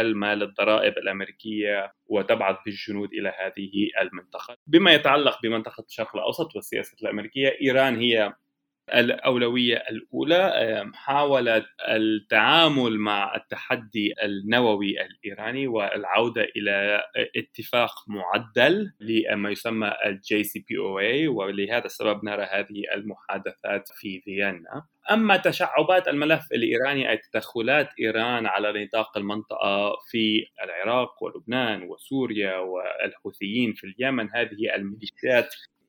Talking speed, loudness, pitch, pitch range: 100 wpm, -24 LUFS, 110 Hz, 100-120 Hz